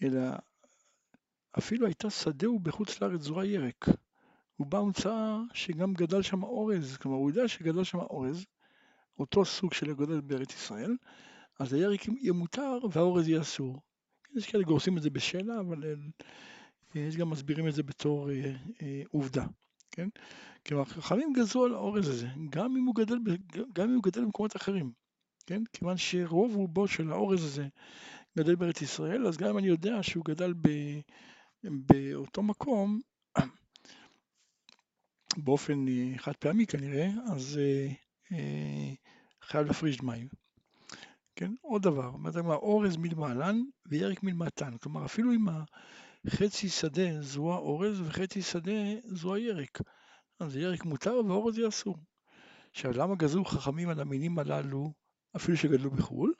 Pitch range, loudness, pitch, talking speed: 150-210 Hz, -32 LUFS, 175 Hz, 145 wpm